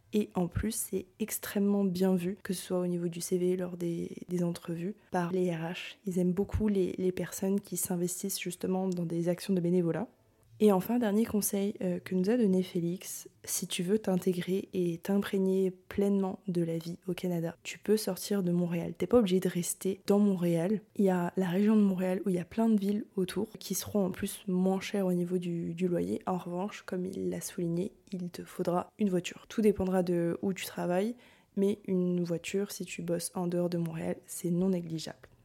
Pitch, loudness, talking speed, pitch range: 185 Hz, -32 LUFS, 210 wpm, 175-200 Hz